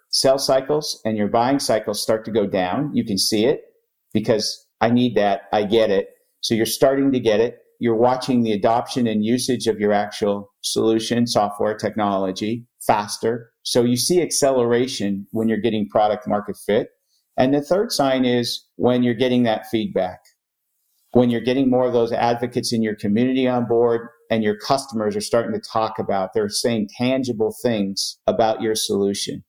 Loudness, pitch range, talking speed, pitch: -20 LUFS, 110-130 Hz, 175 wpm, 120 Hz